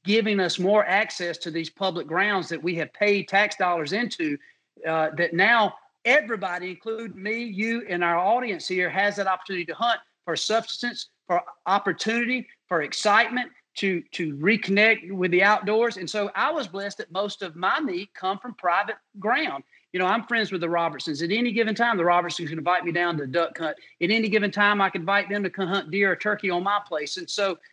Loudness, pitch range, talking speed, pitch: -24 LUFS, 175-215 Hz, 210 wpm, 195 Hz